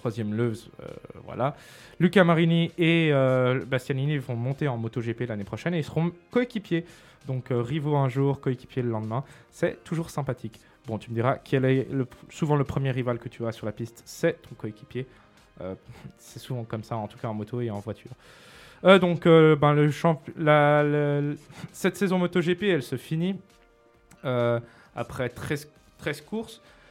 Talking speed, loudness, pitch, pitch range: 185 wpm, -26 LUFS, 135 Hz, 120-160 Hz